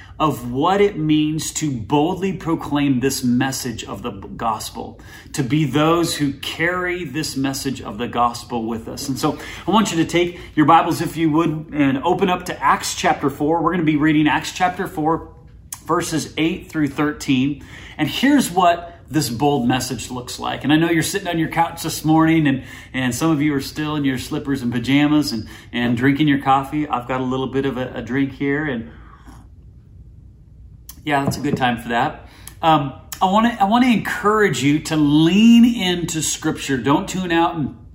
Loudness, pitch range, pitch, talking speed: -19 LUFS, 135-165 Hz, 150 Hz, 195 wpm